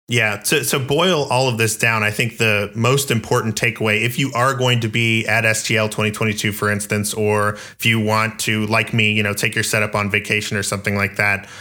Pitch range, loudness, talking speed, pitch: 105-115 Hz, -17 LUFS, 220 wpm, 110 Hz